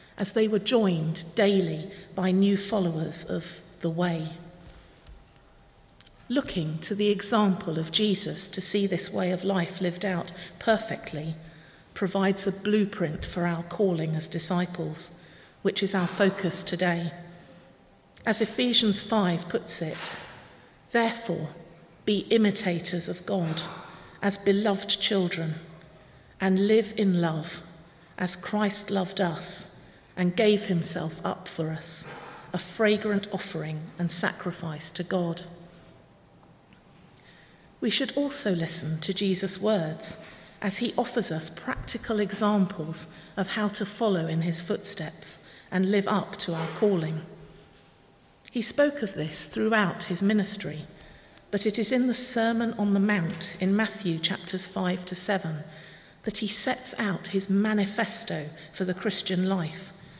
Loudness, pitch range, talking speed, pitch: -27 LUFS, 170-210 Hz, 130 wpm, 190 Hz